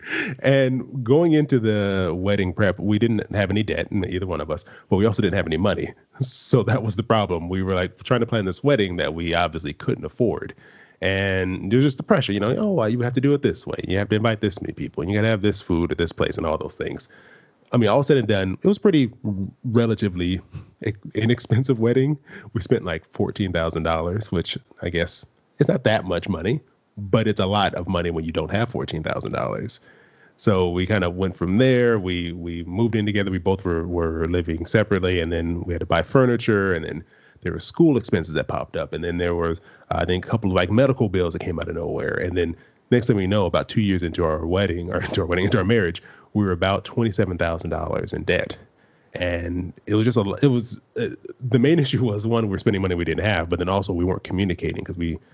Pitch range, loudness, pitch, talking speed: 90-115 Hz, -22 LUFS, 100 Hz, 240 wpm